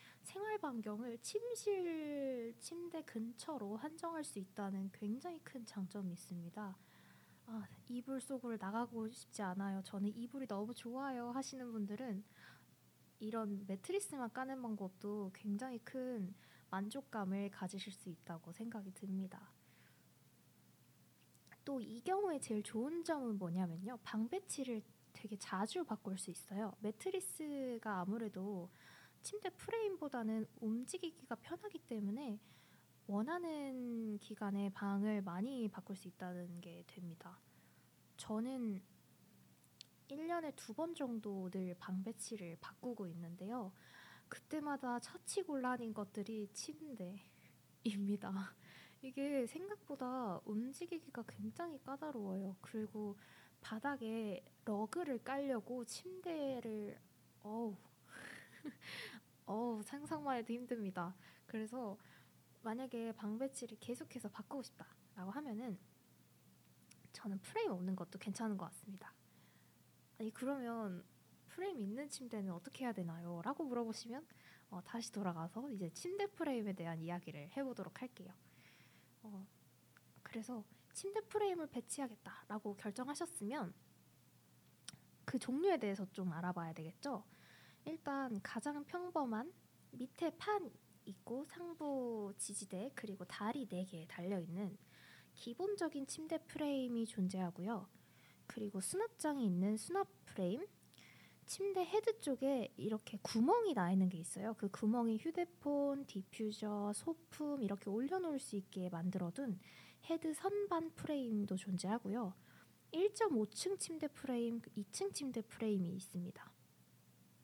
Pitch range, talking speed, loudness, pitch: 195-275 Hz, 265 characters per minute, -44 LUFS, 225 Hz